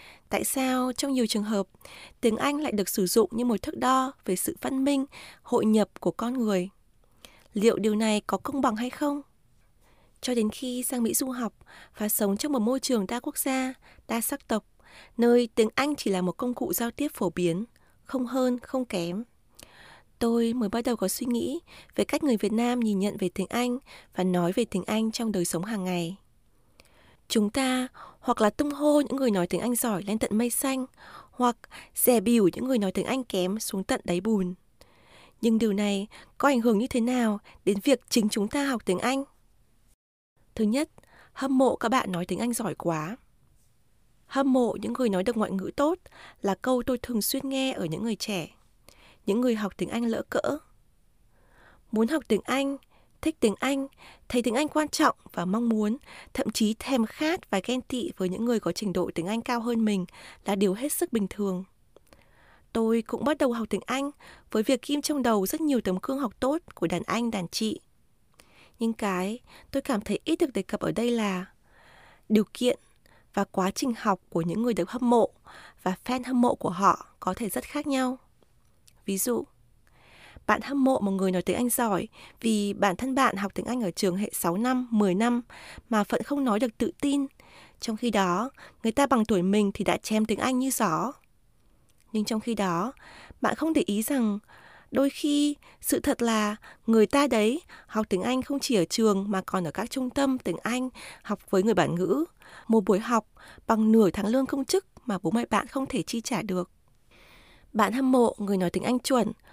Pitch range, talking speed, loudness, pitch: 200-260 Hz, 210 wpm, -27 LUFS, 230 Hz